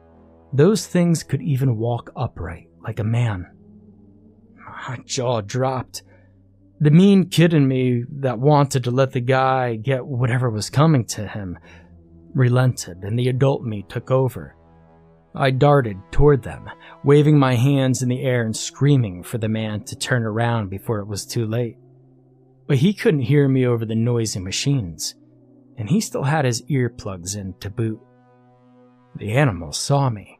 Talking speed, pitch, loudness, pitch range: 160 wpm, 125 Hz, -20 LUFS, 105-135 Hz